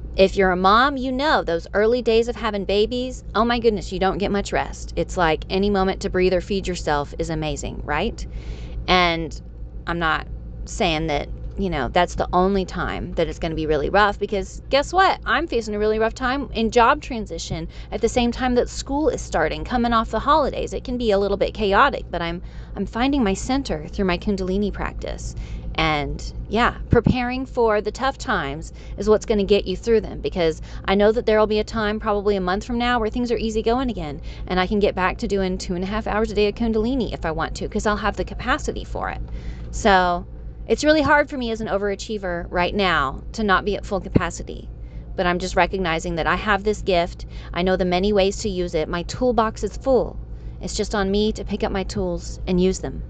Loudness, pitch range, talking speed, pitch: -21 LUFS, 175-225 Hz, 230 wpm, 195 Hz